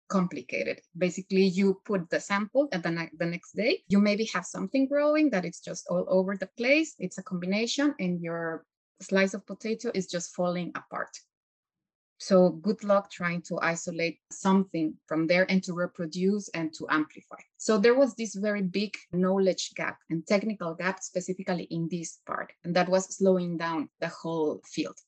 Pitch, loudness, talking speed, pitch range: 185 Hz, -28 LUFS, 175 wpm, 170-200 Hz